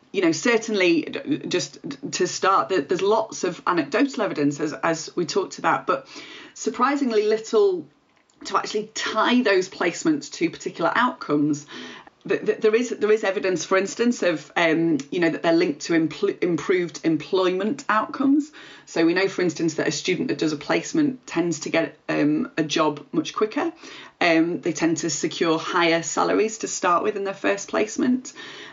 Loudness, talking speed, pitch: -23 LUFS, 165 wpm, 220 Hz